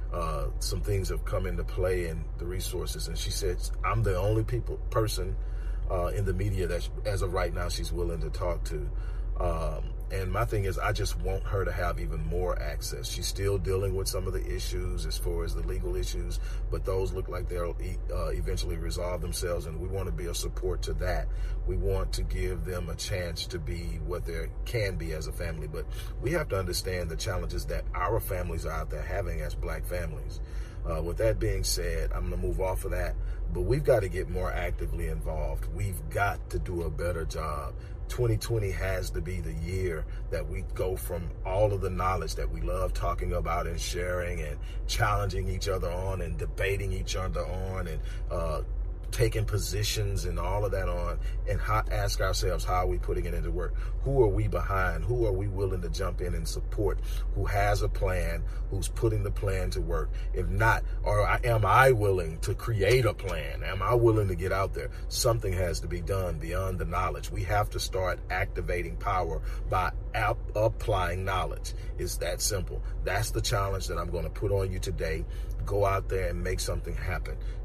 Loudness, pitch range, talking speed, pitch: -31 LUFS, 85-100 Hz, 210 wpm, 95 Hz